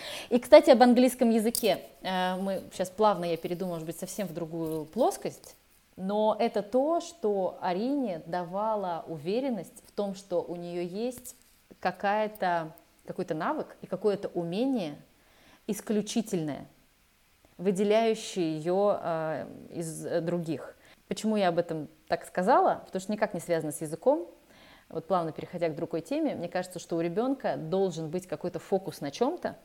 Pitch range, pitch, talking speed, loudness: 170-220 Hz, 185 Hz, 140 wpm, -29 LUFS